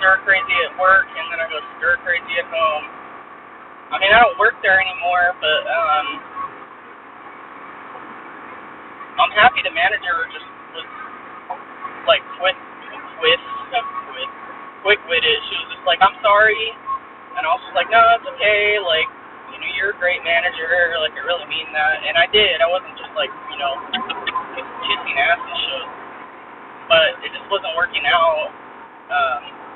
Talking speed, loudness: 160 wpm, -17 LUFS